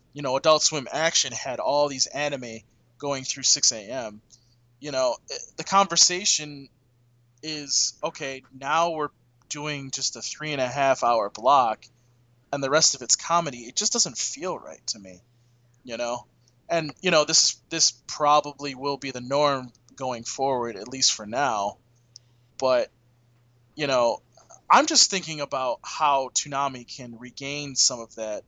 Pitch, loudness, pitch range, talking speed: 135 Hz, -23 LUFS, 120-150 Hz, 160 wpm